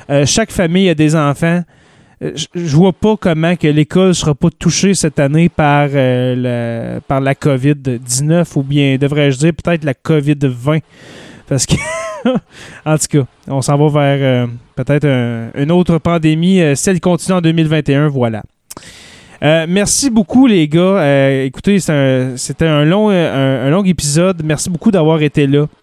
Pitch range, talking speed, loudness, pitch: 140-175 Hz, 175 wpm, -13 LUFS, 150 Hz